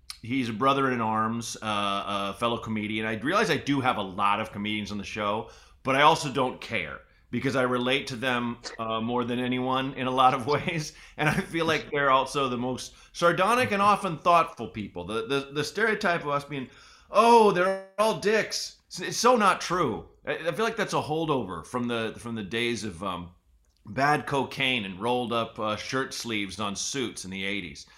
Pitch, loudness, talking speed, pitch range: 125 Hz, -26 LUFS, 205 wpm, 110-150 Hz